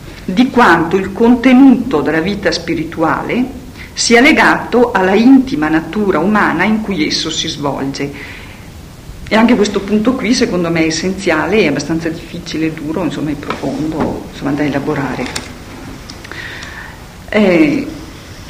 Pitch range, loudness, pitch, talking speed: 155-225 Hz, -13 LUFS, 175 Hz, 125 wpm